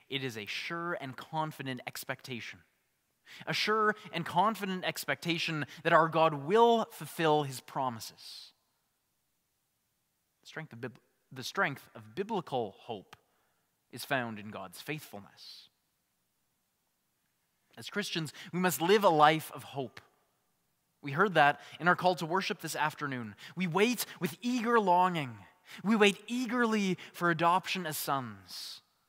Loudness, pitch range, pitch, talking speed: -31 LUFS, 135-185 Hz, 160 Hz, 130 wpm